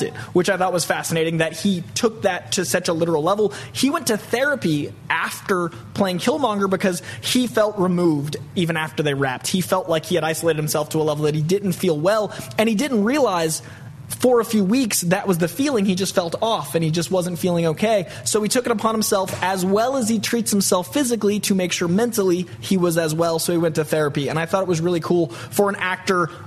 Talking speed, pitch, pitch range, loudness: 235 wpm, 180 Hz, 160-205 Hz, -20 LUFS